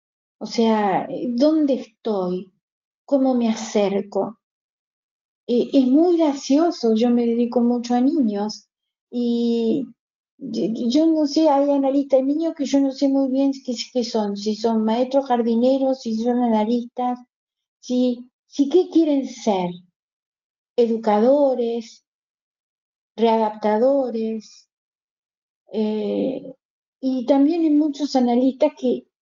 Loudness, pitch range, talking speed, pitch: -20 LUFS, 225-275 Hz, 115 wpm, 245 Hz